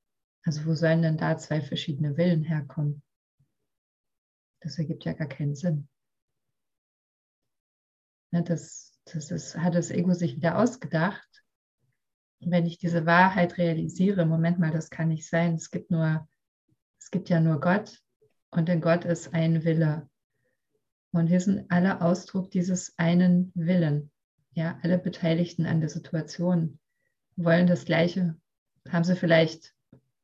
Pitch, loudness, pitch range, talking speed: 165 Hz, -26 LUFS, 155-175 Hz, 135 wpm